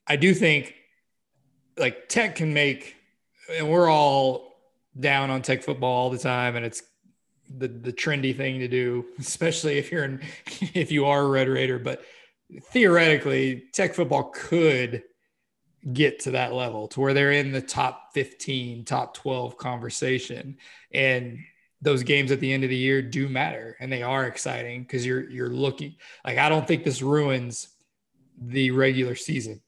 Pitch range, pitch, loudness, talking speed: 125-150 Hz, 135 Hz, -24 LUFS, 165 wpm